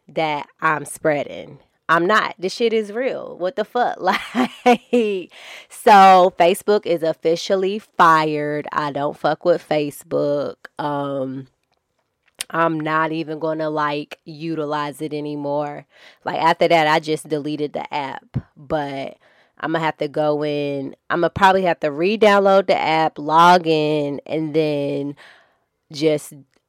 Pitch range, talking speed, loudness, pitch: 150-175 Hz, 135 wpm, -19 LUFS, 155 Hz